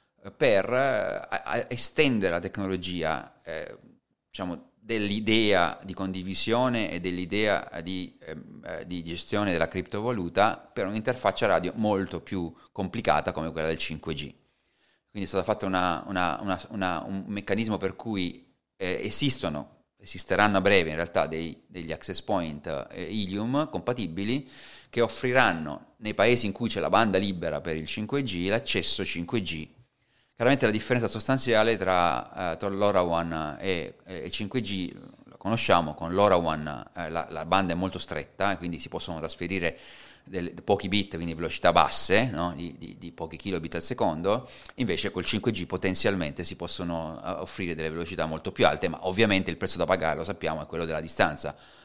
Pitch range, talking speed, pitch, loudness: 85-105 Hz, 150 wpm, 95 Hz, -27 LUFS